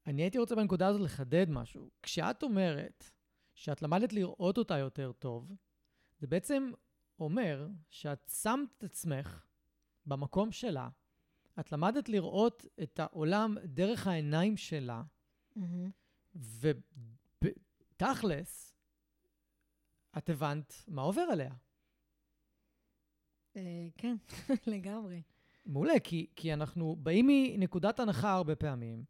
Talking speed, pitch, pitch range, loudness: 100 wpm, 170 Hz, 145-200 Hz, -35 LUFS